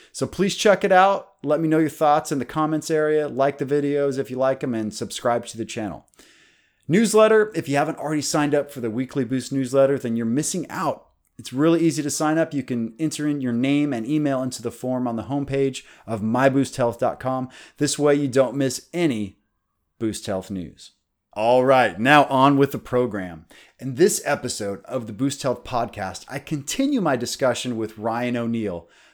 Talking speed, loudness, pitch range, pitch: 195 wpm, -22 LUFS, 115-150 Hz, 135 Hz